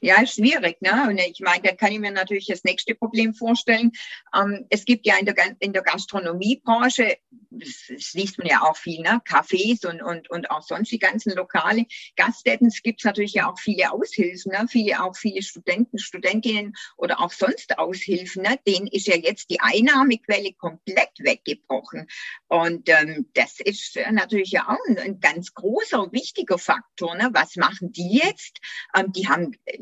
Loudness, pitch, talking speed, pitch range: -21 LUFS, 205 Hz, 175 wpm, 185-230 Hz